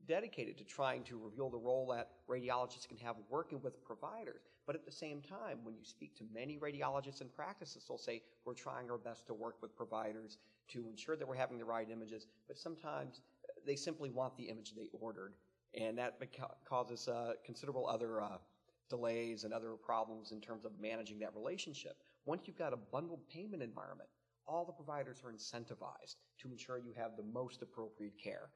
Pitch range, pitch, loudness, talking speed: 110-130 Hz, 120 Hz, -46 LUFS, 195 wpm